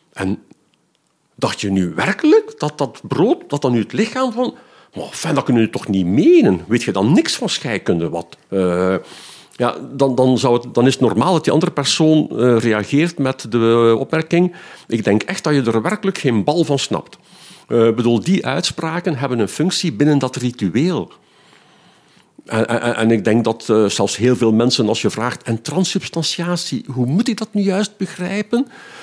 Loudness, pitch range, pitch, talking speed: -17 LUFS, 115-175 Hz, 130 Hz, 190 wpm